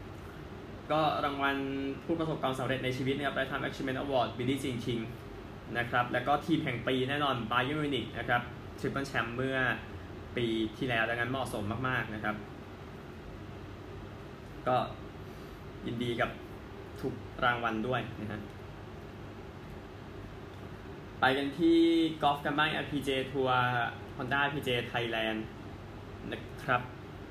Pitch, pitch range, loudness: 120 Hz, 105-135 Hz, -32 LUFS